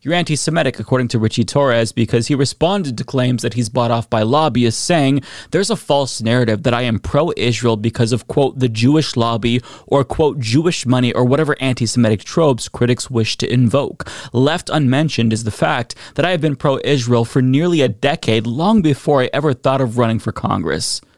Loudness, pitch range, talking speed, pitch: -16 LUFS, 115-145 Hz, 200 wpm, 125 Hz